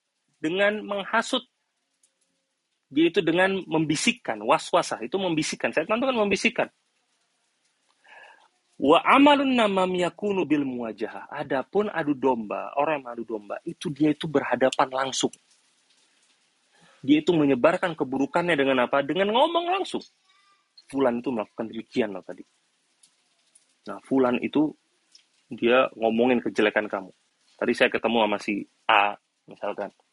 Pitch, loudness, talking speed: 155 Hz, -24 LUFS, 115 wpm